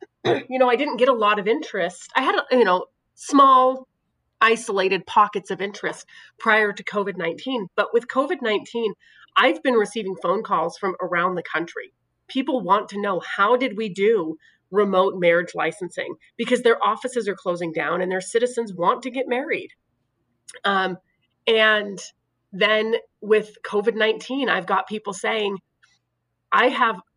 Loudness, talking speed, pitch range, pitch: -21 LUFS, 155 wpm, 195-250 Hz, 215 Hz